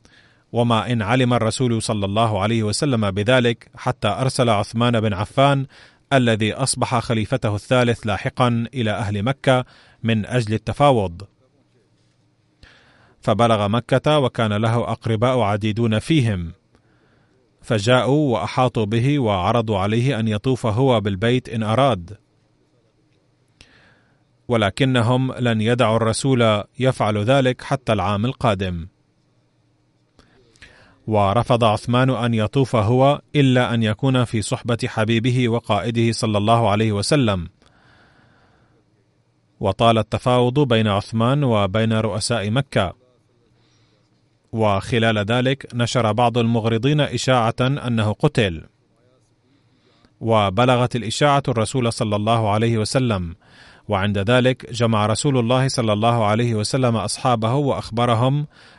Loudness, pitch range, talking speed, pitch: -19 LUFS, 110-125 Hz, 105 wpm, 115 Hz